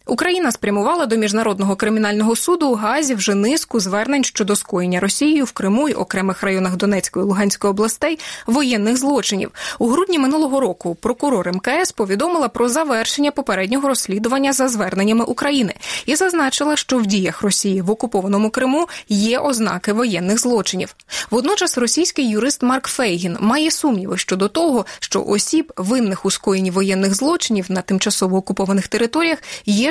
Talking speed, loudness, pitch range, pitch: 145 wpm, -17 LUFS, 200-275 Hz, 225 Hz